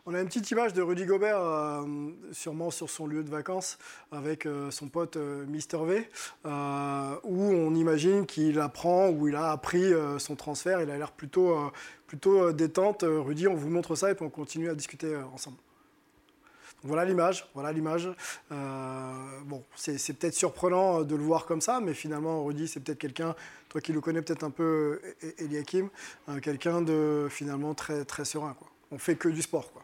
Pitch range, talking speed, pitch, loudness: 150-170 Hz, 180 wpm, 155 Hz, -30 LUFS